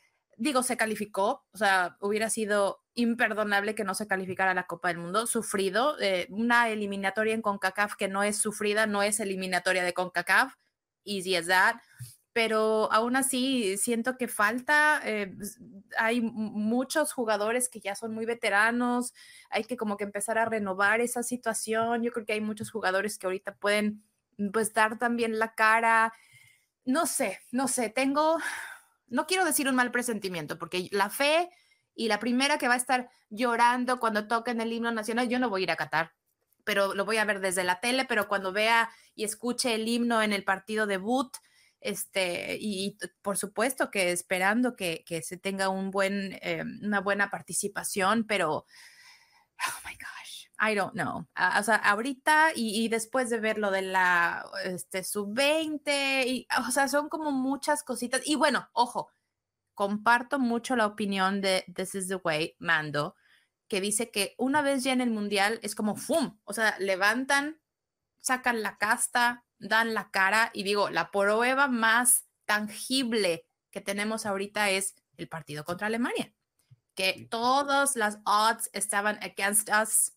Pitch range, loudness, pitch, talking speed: 195-245 Hz, -28 LUFS, 215 Hz, 170 wpm